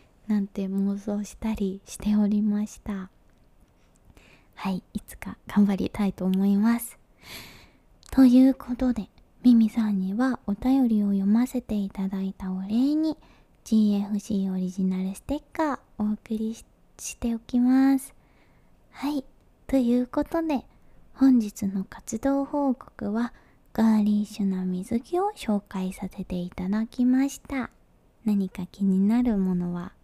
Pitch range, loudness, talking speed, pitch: 195-250 Hz, -26 LUFS, 255 characters per minute, 210 Hz